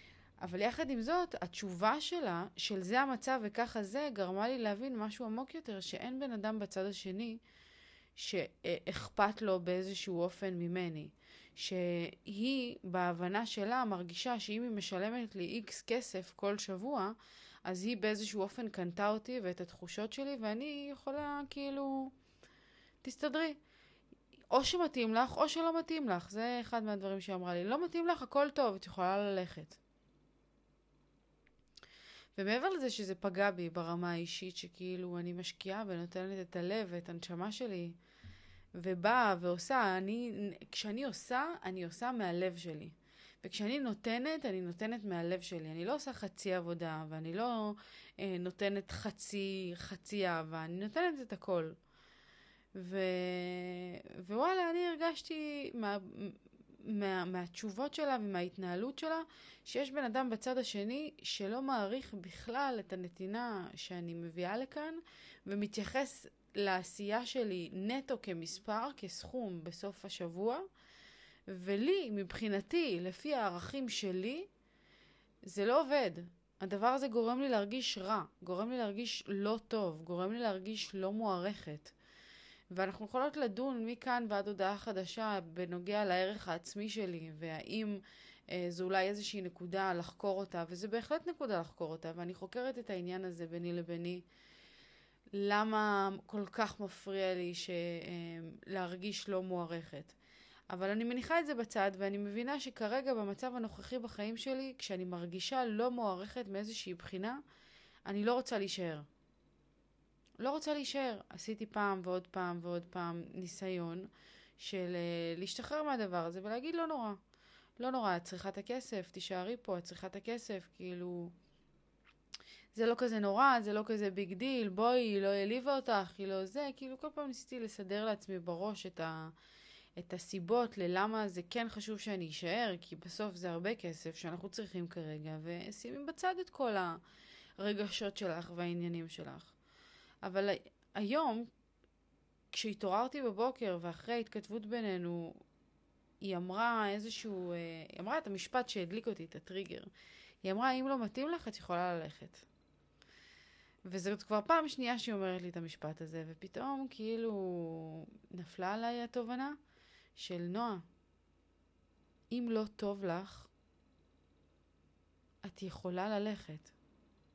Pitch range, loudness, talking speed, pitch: 180-235 Hz, -39 LUFS, 130 wpm, 200 Hz